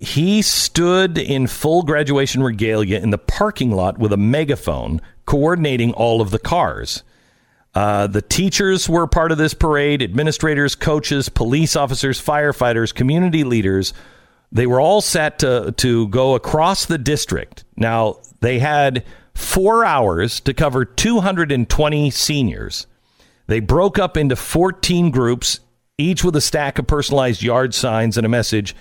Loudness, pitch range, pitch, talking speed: -17 LUFS, 115-155 Hz, 135 Hz, 145 wpm